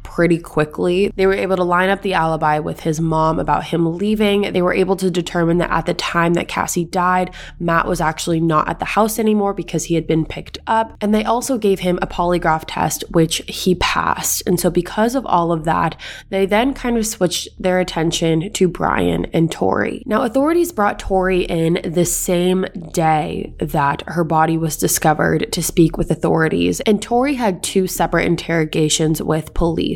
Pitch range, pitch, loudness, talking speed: 165-195 Hz, 175 Hz, -17 LUFS, 190 wpm